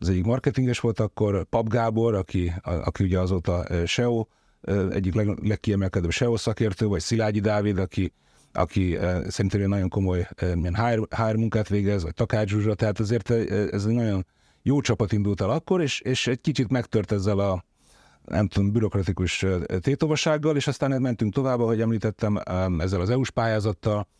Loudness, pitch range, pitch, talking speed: -25 LUFS, 95-115 Hz, 105 Hz, 155 wpm